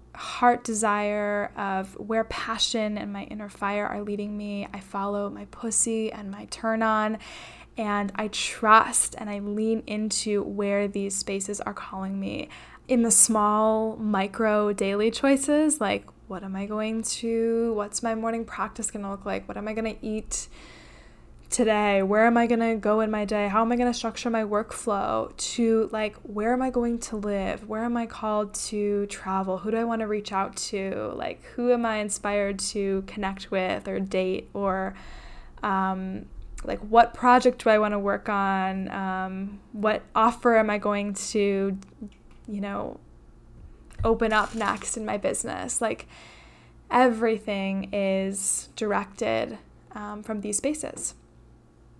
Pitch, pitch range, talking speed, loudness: 210 Hz, 200-225 Hz, 165 wpm, -26 LUFS